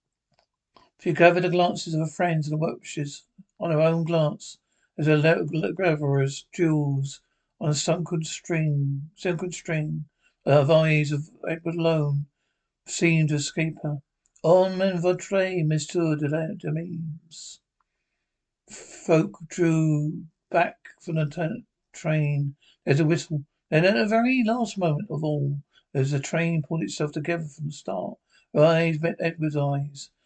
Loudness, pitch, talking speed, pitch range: -25 LUFS, 160 Hz, 145 wpm, 150-170 Hz